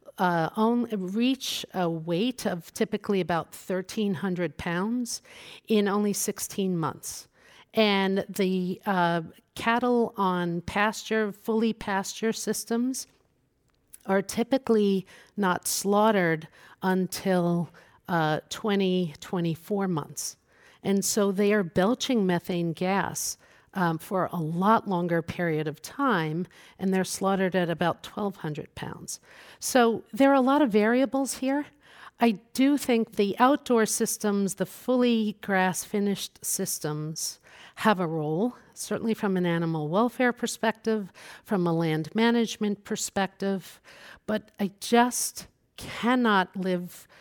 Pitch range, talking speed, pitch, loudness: 180-225 Hz, 115 wpm, 195 Hz, -27 LUFS